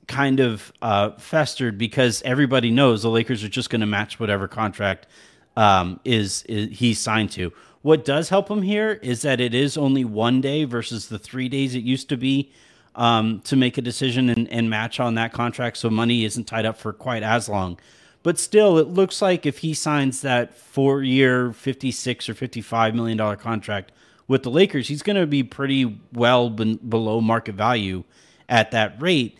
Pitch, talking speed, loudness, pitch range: 120 Hz, 190 wpm, -21 LUFS, 110-135 Hz